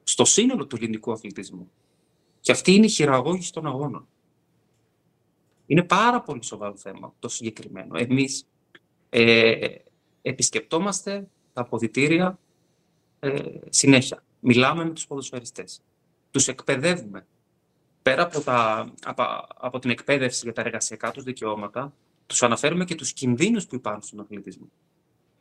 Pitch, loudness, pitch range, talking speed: 130 Hz, -23 LUFS, 115-160 Hz, 125 wpm